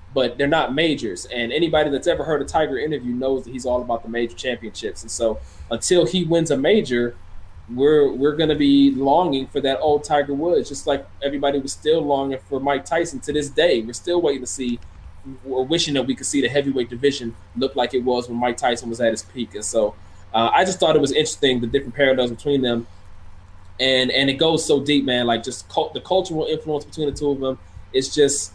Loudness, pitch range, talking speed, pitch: -20 LUFS, 115-145 Hz, 230 wpm, 130 Hz